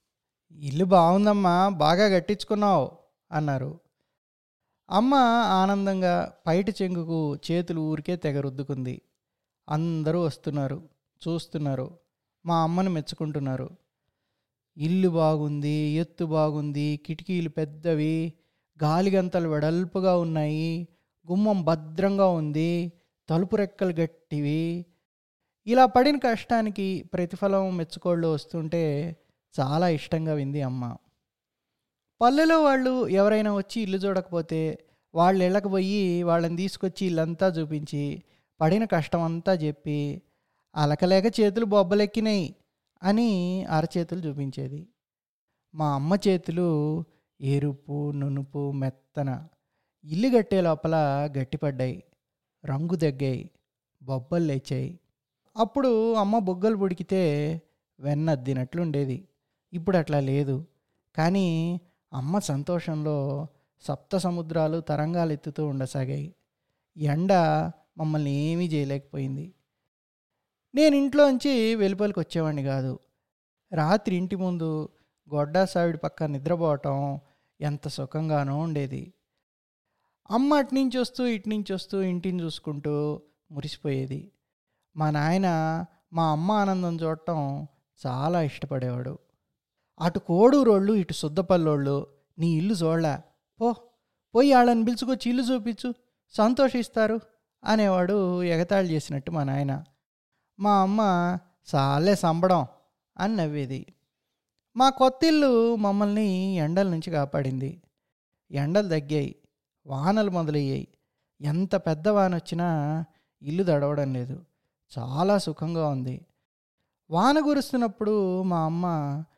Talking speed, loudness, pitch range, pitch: 90 wpm, -26 LUFS, 145-190 Hz, 165 Hz